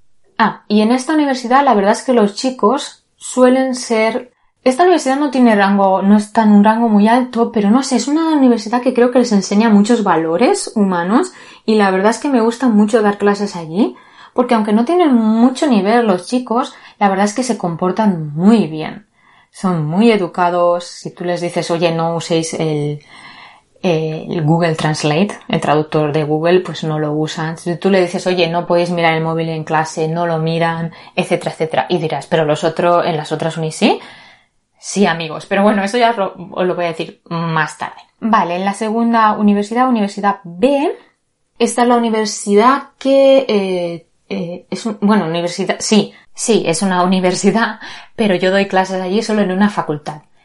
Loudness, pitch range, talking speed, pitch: -14 LUFS, 170-230 Hz, 190 wpm, 200 Hz